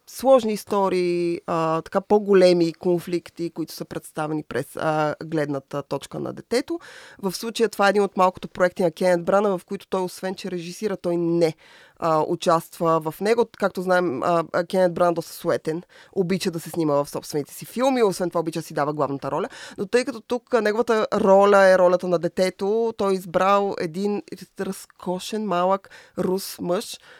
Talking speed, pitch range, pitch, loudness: 175 wpm, 170-200 Hz, 180 Hz, -23 LUFS